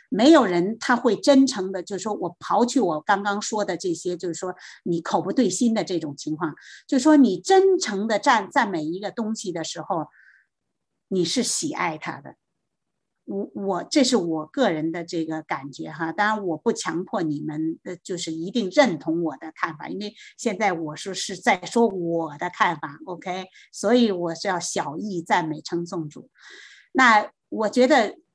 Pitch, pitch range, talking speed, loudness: 185 Hz, 165-225 Hz, 255 characters per minute, -23 LUFS